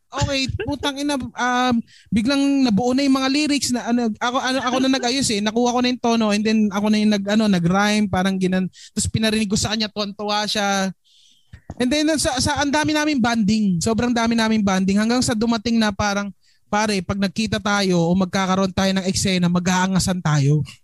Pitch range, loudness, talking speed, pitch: 195-245 Hz, -19 LUFS, 195 wpm, 215 Hz